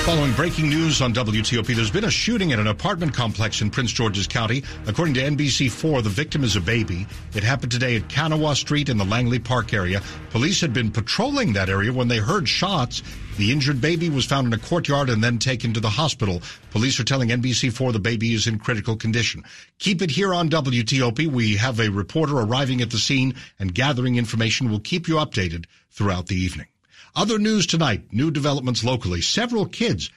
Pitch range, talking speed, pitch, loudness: 110-150 Hz, 200 wpm, 125 Hz, -21 LUFS